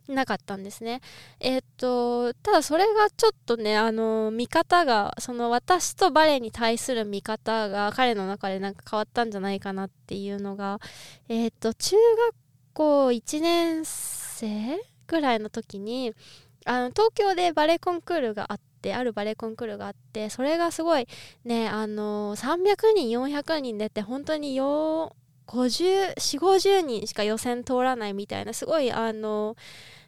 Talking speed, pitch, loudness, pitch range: 295 characters per minute, 240 Hz, -26 LUFS, 215-310 Hz